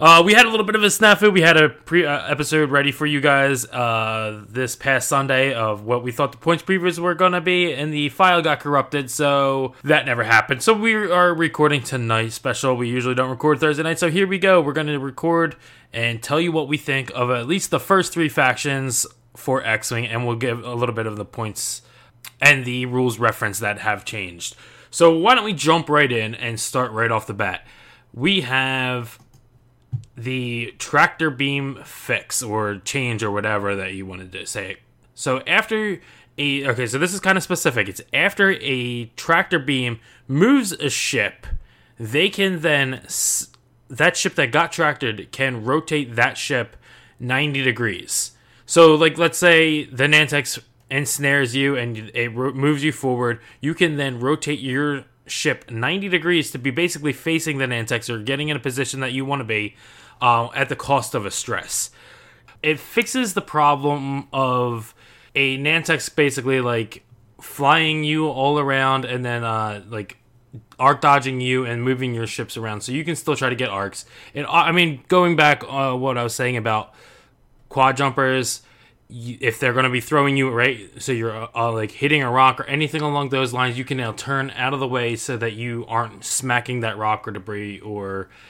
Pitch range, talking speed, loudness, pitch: 120-150 Hz, 190 wpm, -19 LUFS, 130 Hz